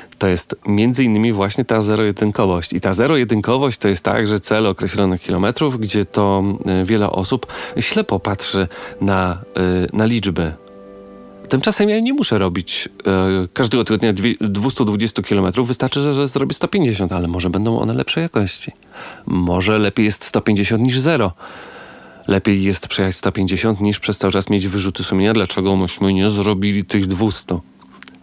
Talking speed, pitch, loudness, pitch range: 155 wpm, 100 Hz, -17 LUFS, 95-115 Hz